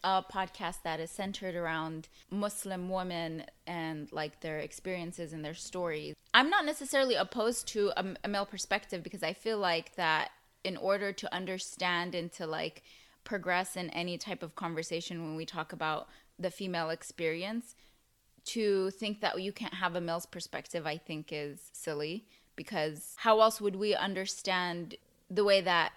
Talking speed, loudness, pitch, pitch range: 165 wpm, -34 LUFS, 180 Hz, 165-200 Hz